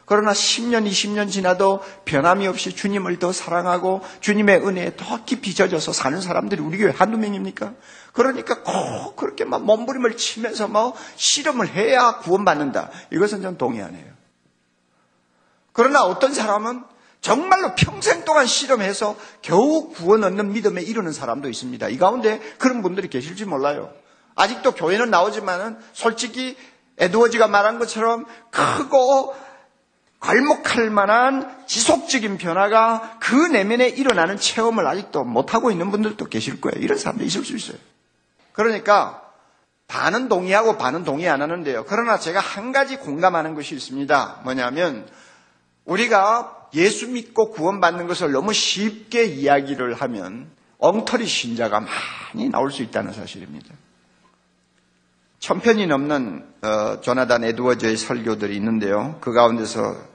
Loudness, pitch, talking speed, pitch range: -20 LUFS, 205 Hz, 325 characters per minute, 160-235 Hz